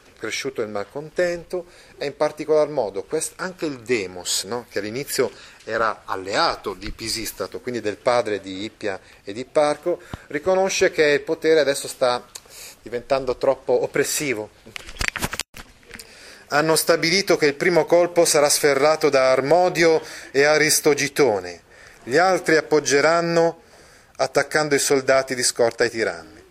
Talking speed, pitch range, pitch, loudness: 125 wpm, 135-170 Hz, 150 Hz, -21 LUFS